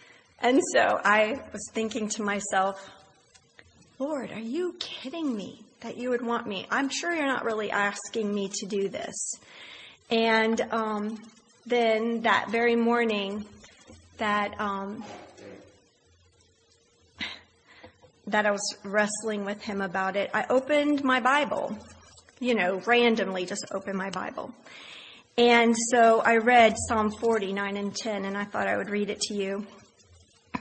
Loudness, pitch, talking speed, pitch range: -26 LUFS, 215 Hz, 140 wpm, 200-235 Hz